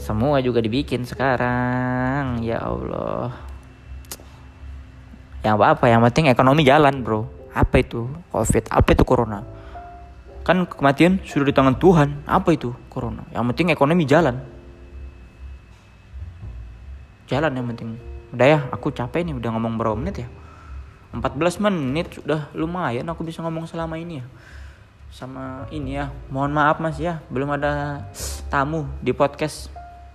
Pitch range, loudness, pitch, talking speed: 100-145 Hz, -21 LUFS, 125 Hz, 135 wpm